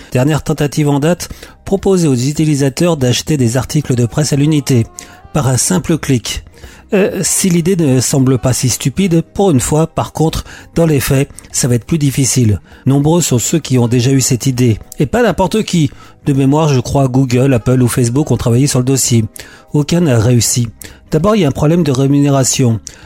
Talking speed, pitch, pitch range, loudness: 200 wpm, 135 Hz, 125-155 Hz, -12 LUFS